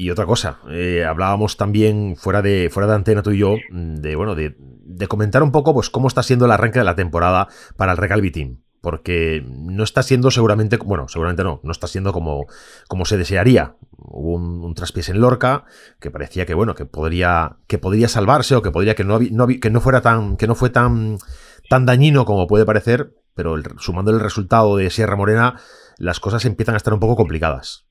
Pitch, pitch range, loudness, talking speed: 105 Hz, 90-115 Hz, -17 LUFS, 210 wpm